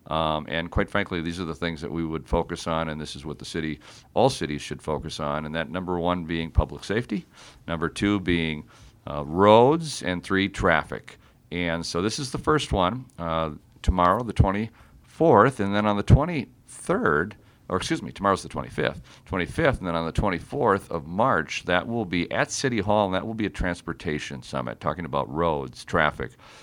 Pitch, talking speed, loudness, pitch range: 85 Hz, 195 wpm, -25 LUFS, 80-100 Hz